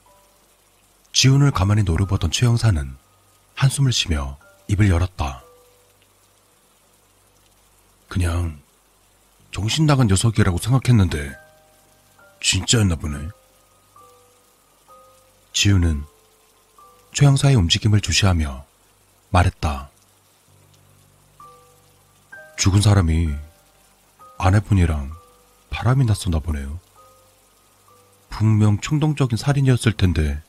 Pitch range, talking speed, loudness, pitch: 90-105 Hz, 190 characters per minute, -19 LUFS, 100 Hz